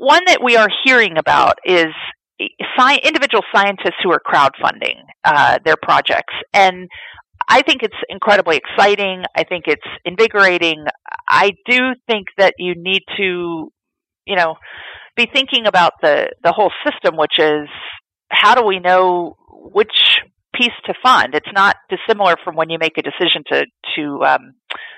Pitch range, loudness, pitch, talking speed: 170-240 Hz, -14 LUFS, 190 Hz, 155 wpm